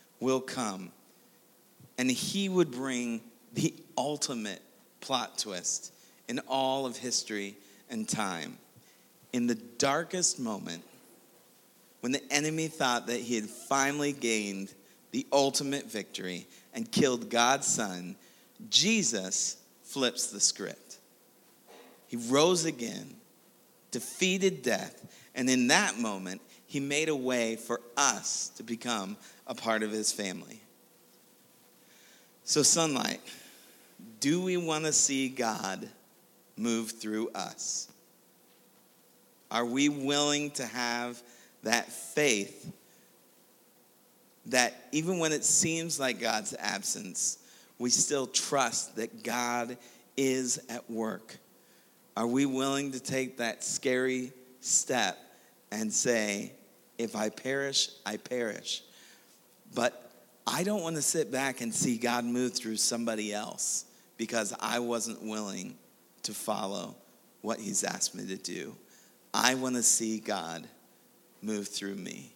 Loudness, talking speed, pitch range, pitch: -30 LUFS, 120 wpm, 115-145 Hz, 125 Hz